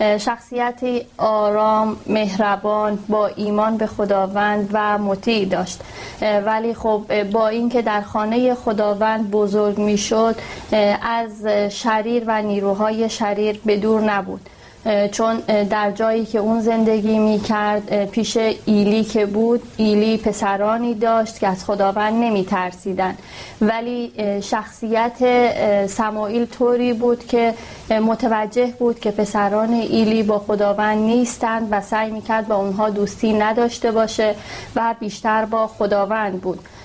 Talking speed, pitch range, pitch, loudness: 120 wpm, 210-225 Hz, 215 Hz, -19 LUFS